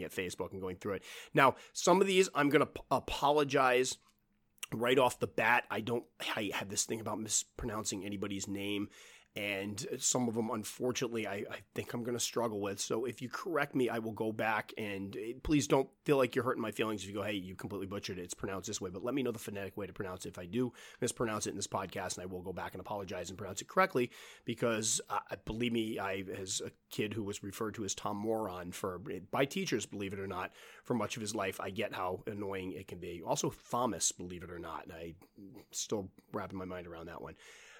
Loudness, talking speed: -36 LUFS, 240 wpm